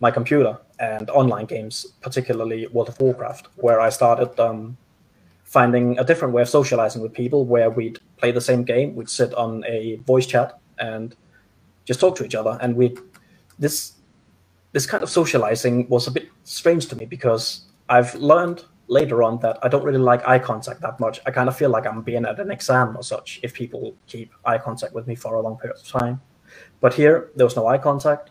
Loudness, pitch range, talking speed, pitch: -20 LUFS, 115-135 Hz, 210 wpm, 125 Hz